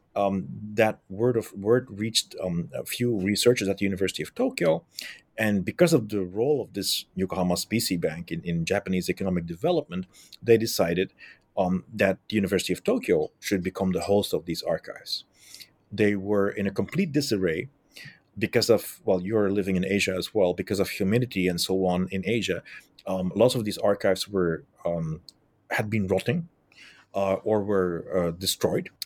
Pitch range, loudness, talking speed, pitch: 95-110 Hz, -26 LUFS, 170 wpm, 100 Hz